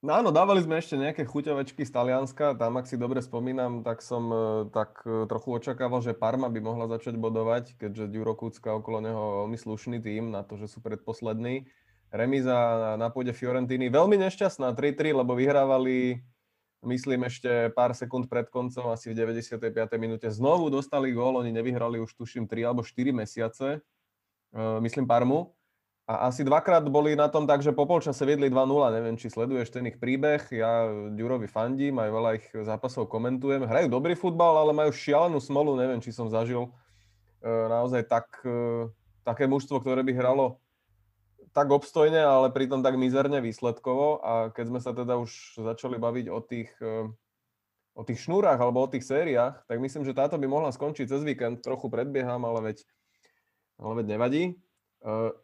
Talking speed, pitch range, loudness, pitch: 165 wpm, 115-135 Hz, -28 LUFS, 125 Hz